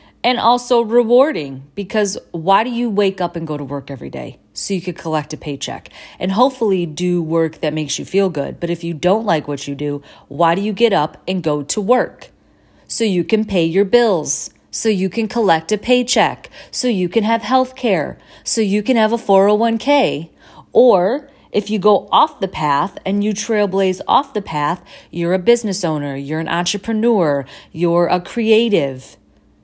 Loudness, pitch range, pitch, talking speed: -17 LUFS, 160-225 Hz, 195 Hz, 190 wpm